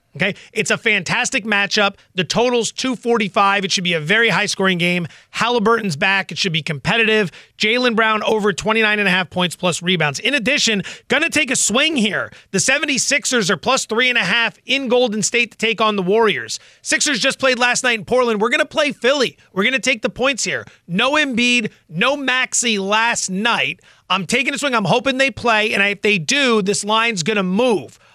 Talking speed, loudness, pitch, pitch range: 200 wpm, -16 LUFS, 220 Hz, 195-250 Hz